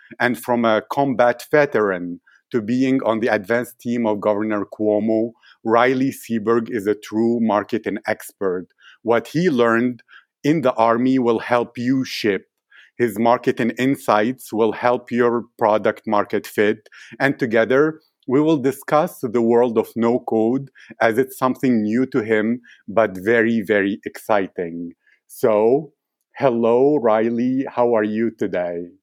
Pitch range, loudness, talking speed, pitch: 110-130 Hz, -19 LUFS, 140 wpm, 120 Hz